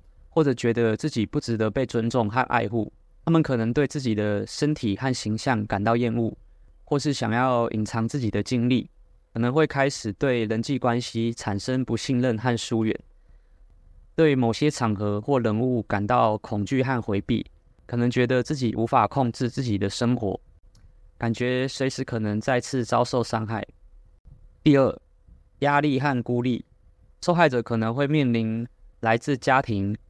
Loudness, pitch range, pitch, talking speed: -24 LUFS, 105-130 Hz, 115 Hz, 245 characters per minute